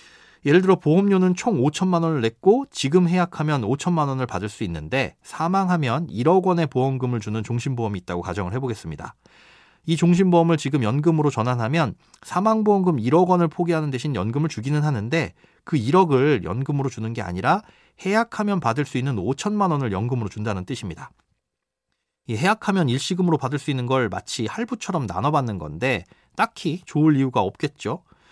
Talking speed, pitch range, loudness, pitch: 370 characters per minute, 125-180 Hz, -22 LUFS, 150 Hz